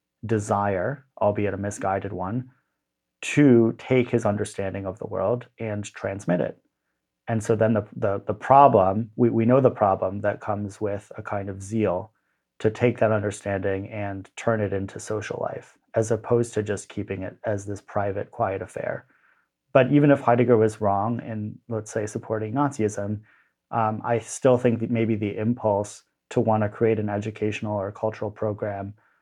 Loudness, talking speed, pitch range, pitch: -24 LUFS, 170 wpm, 100-115 Hz, 105 Hz